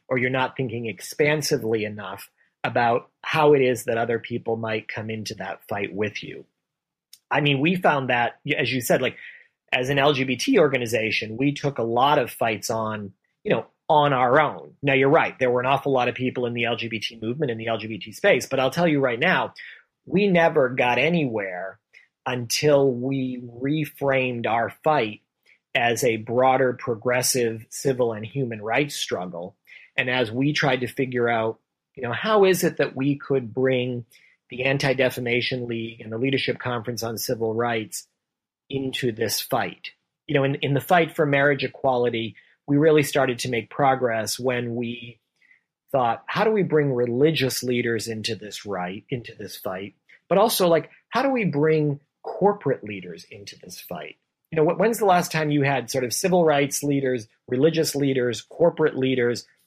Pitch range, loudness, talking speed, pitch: 115-145 Hz, -23 LUFS, 175 wpm, 130 Hz